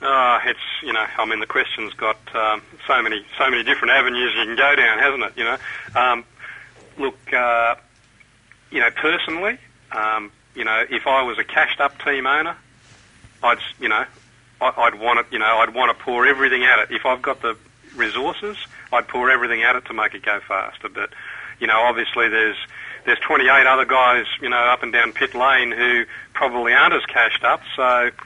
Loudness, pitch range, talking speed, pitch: -18 LUFS, 110-130 Hz, 200 wpm, 120 Hz